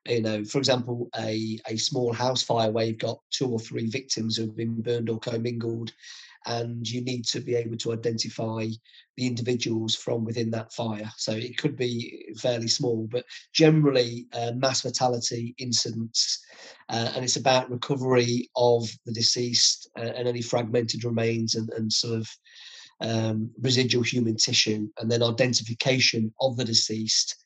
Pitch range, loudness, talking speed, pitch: 115-125 Hz, -26 LUFS, 160 wpm, 120 Hz